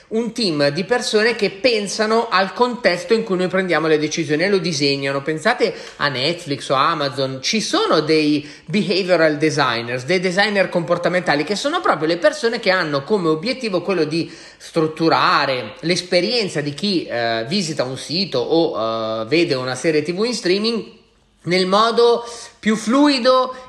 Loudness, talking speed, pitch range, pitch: -18 LUFS, 155 wpm, 155-220 Hz, 180 Hz